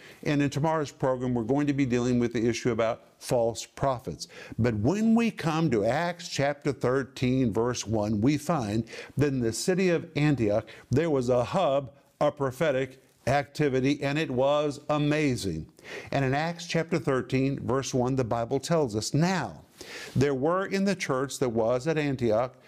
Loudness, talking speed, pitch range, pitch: -27 LUFS, 170 wpm, 125-150 Hz, 140 Hz